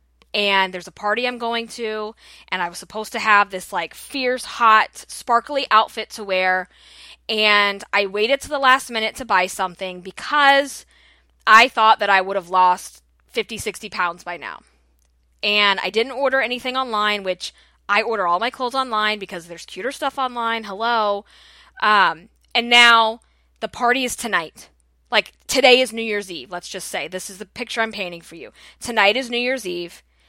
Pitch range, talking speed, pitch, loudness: 185-240 Hz, 180 wpm, 215 Hz, -19 LUFS